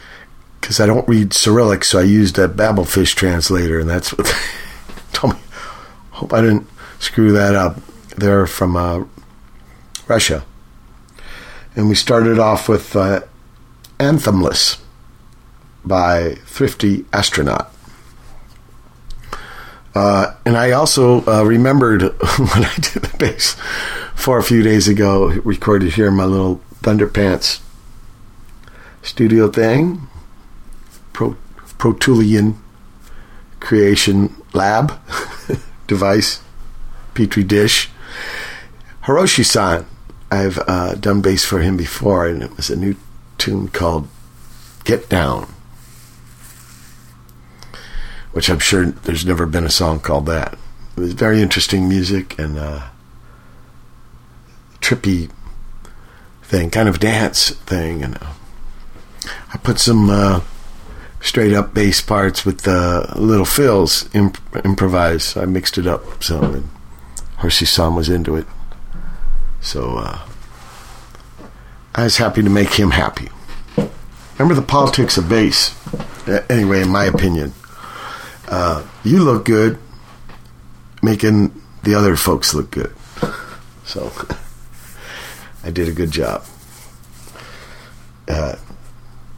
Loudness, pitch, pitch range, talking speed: -15 LUFS, 100 Hz, 85-110 Hz, 115 wpm